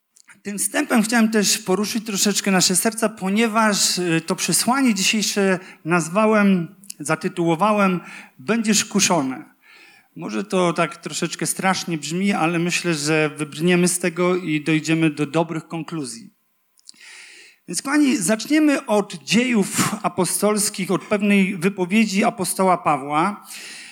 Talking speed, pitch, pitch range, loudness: 110 wpm, 190 Hz, 175-215 Hz, -20 LUFS